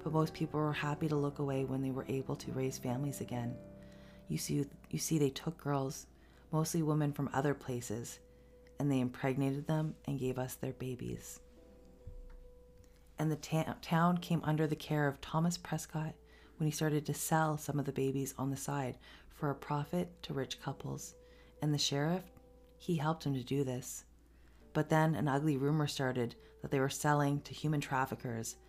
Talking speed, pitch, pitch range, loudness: 185 wpm, 140 Hz, 130-155 Hz, -36 LUFS